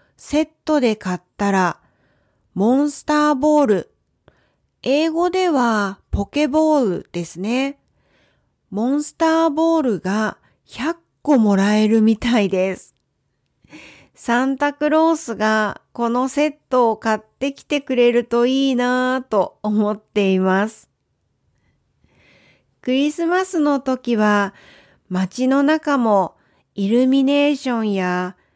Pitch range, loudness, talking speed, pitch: 210-290 Hz, -19 LUFS, 215 characters per minute, 245 Hz